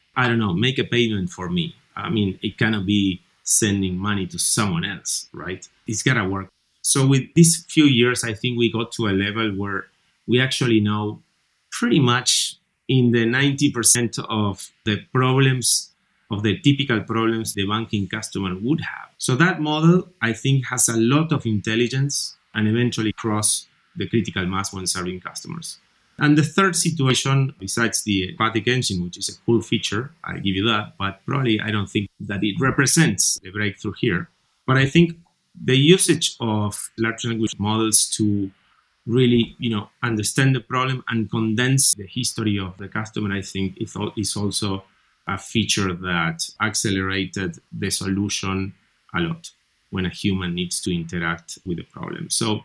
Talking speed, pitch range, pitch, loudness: 170 wpm, 100-130 Hz, 110 Hz, -21 LUFS